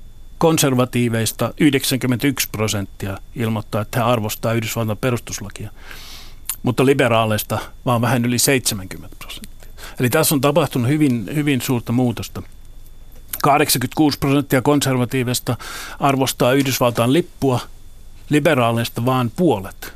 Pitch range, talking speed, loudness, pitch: 110-135 Hz, 100 wpm, -18 LUFS, 125 Hz